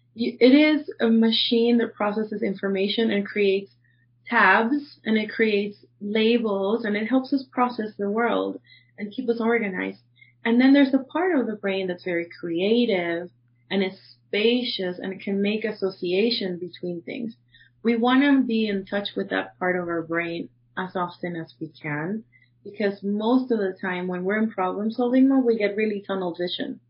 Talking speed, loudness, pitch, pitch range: 180 wpm, -23 LUFS, 205 Hz, 175-230 Hz